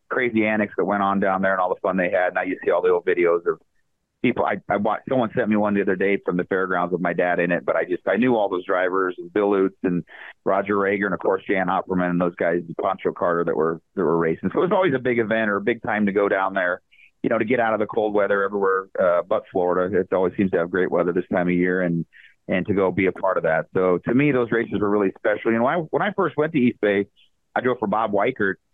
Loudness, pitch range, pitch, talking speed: -22 LUFS, 95-120 Hz, 100 Hz, 295 wpm